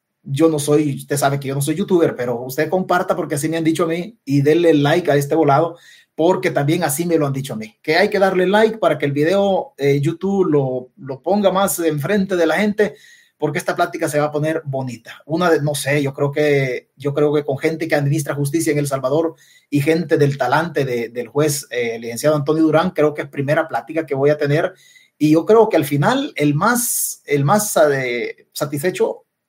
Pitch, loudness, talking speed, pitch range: 155 Hz, -18 LUFS, 230 wpm, 145-175 Hz